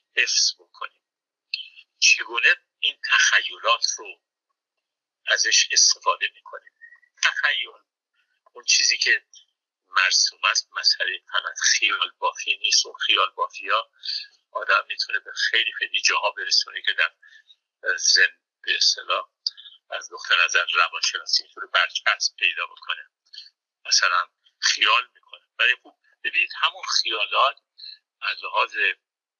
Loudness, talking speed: -21 LUFS, 105 wpm